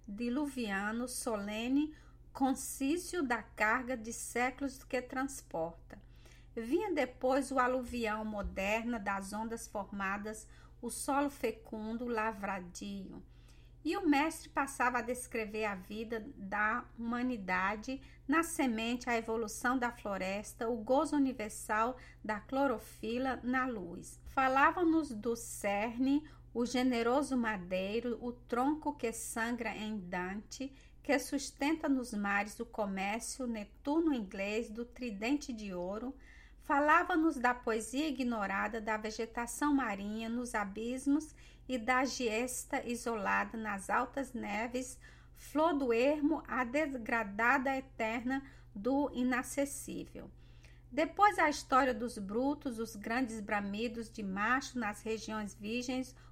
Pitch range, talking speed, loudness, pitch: 215-265 Hz, 110 wpm, -35 LUFS, 240 Hz